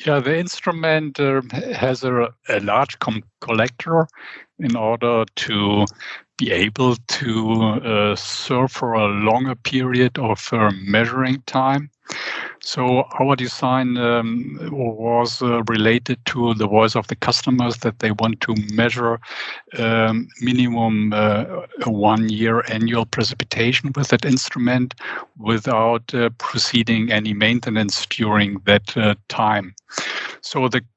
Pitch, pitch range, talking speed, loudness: 115 Hz, 110-130 Hz, 130 wpm, -19 LUFS